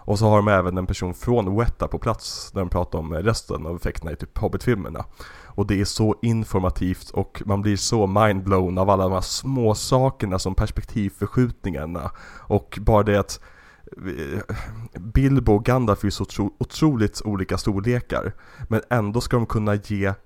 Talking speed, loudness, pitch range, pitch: 170 wpm, -23 LUFS, 95-115 Hz, 100 Hz